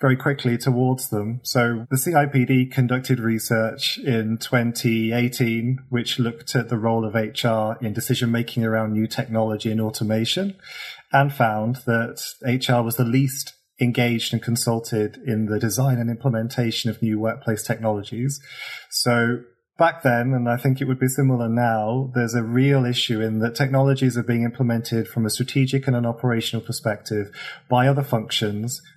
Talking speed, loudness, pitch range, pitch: 155 wpm, -22 LUFS, 115-130 Hz, 120 Hz